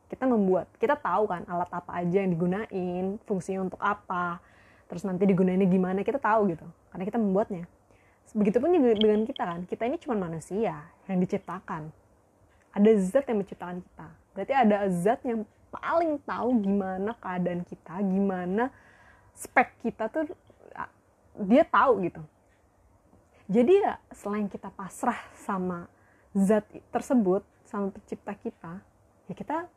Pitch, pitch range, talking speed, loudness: 195 Hz, 180-225 Hz, 135 wpm, -27 LUFS